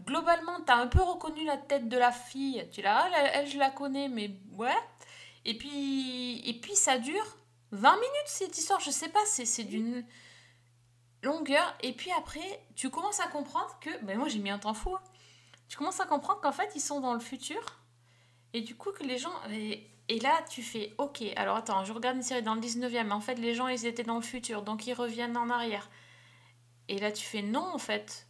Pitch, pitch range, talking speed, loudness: 250 Hz, 215-295 Hz, 225 wpm, -32 LUFS